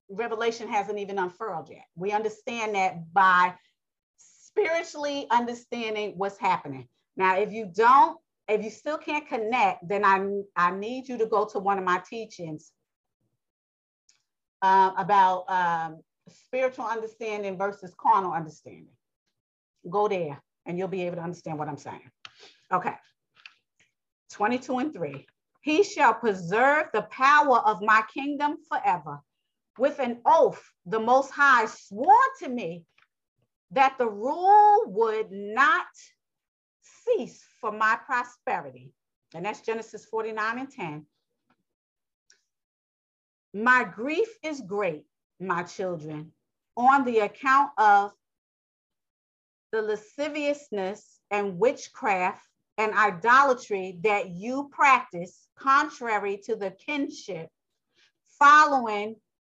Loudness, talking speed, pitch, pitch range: -25 LUFS, 115 wpm, 215 Hz, 185-260 Hz